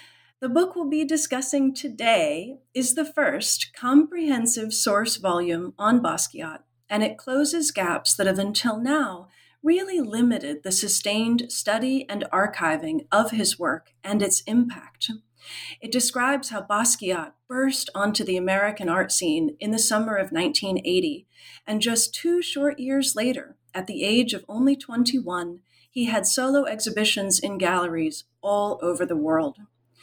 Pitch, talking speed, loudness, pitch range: 230 Hz, 145 wpm, -23 LUFS, 200-280 Hz